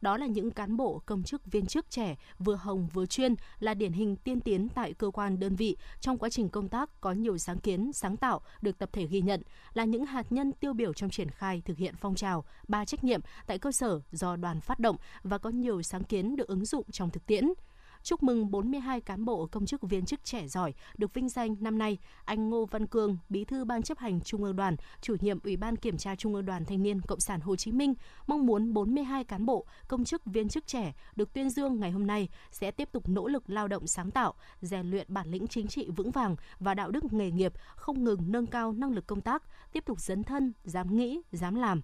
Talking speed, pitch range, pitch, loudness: 245 wpm, 195-245 Hz, 210 Hz, -33 LUFS